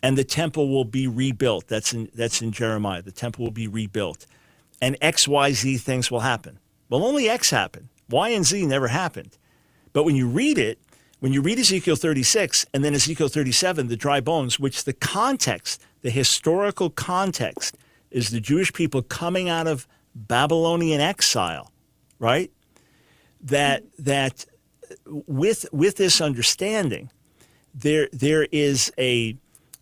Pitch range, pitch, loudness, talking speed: 125-160 Hz, 140 Hz, -22 LUFS, 150 wpm